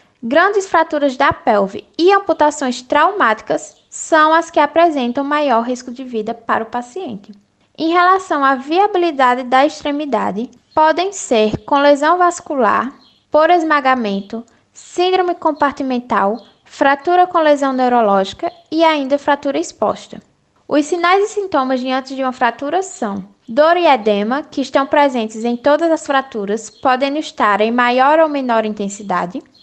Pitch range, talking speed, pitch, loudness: 245-325 Hz, 135 wpm, 280 Hz, -15 LUFS